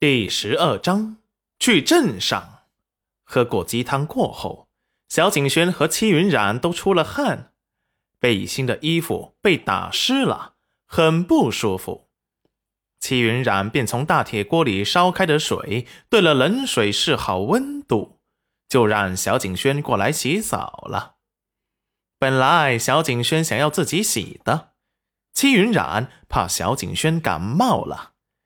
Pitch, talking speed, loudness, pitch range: 155 Hz, 190 characters per minute, -20 LUFS, 125-185 Hz